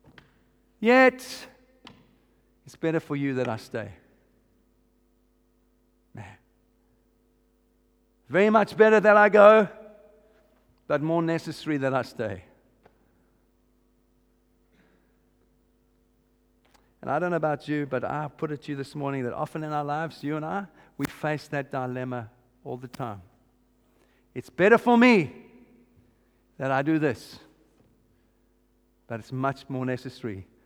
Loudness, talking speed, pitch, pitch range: -24 LUFS, 125 wpm, 145 Hz, 125-170 Hz